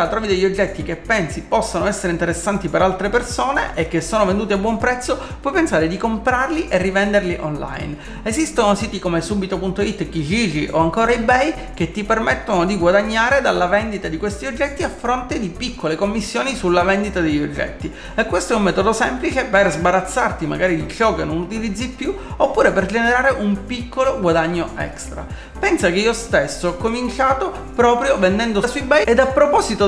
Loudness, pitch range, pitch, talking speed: -18 LUFS, 175-240 Hz, 205 Hz, 175 wpm